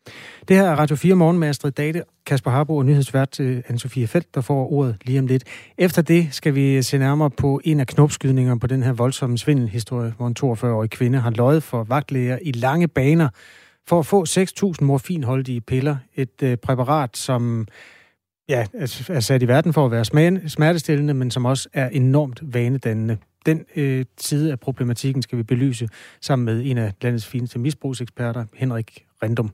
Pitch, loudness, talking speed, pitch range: 135 Hz, -20 LUFS, 180 wpm, 125-150 Hz